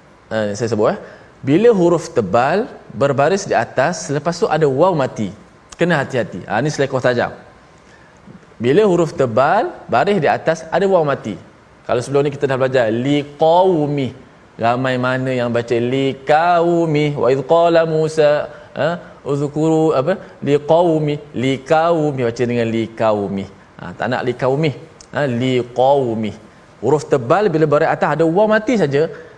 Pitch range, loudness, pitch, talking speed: 120-160 Hz, -16 LUFS, 140 Hz, 140 wpm